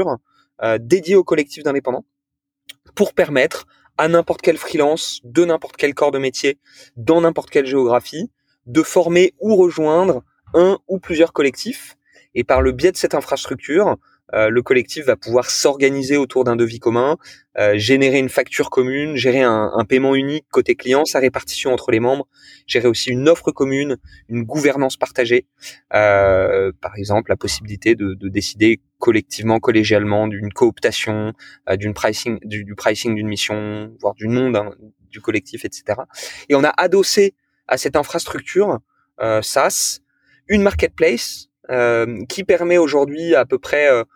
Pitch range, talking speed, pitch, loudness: 110-160 Hz, 160 wpm, 130 Hz, -17 LUFS